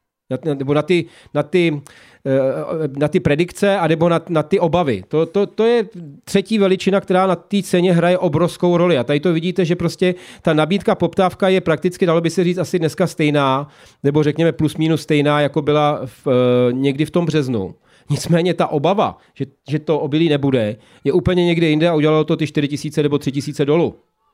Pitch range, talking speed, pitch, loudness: 145-180 Hz, 195 wpm, 160 Hz, -17 LUFS